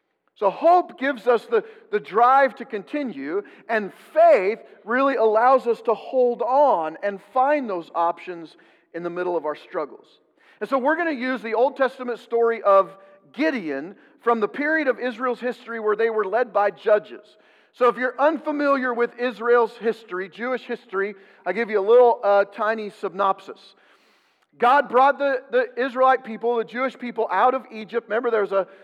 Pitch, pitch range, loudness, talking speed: 235 Hz, 210-265 Hz, -22 LUFS, 175 wpm